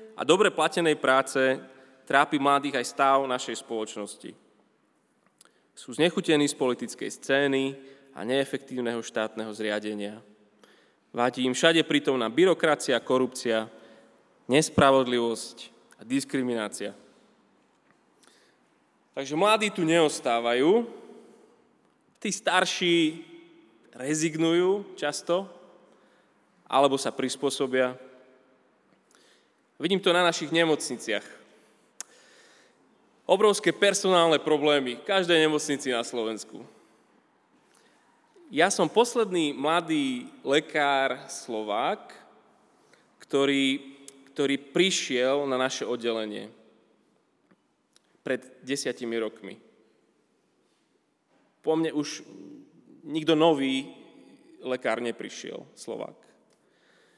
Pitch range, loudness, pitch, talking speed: 125-165 Hz, -26 LUFS, 135 Hz, 80 wpm